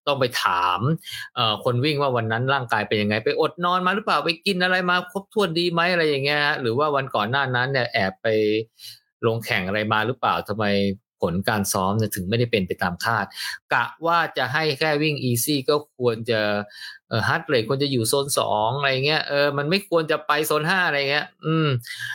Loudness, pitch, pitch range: -22 LUFS, 140 Hz, 110-155 Hz